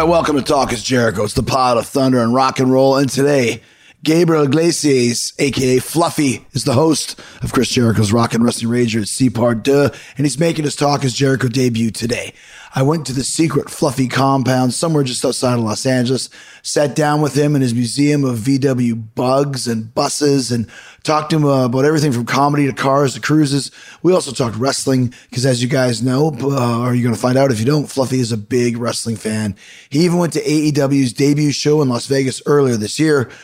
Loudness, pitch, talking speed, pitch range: -16 LUFS, 135 Hz, 210 wpm, 120-145 Hz